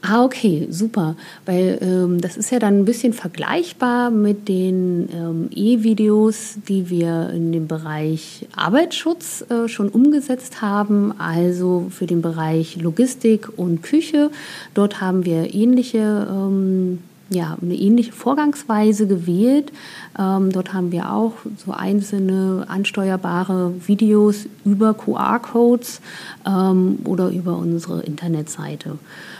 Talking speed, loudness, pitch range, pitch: 120 wpm, -19 LUFS, 180-225 Hz, 195 Hz